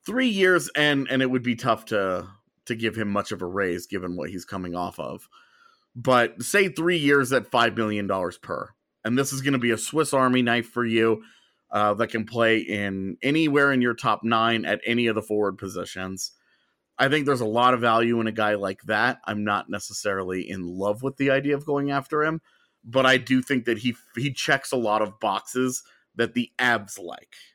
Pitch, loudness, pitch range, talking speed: 120 Hz, -24 LUFS, 105-135 Hz, 215 wpm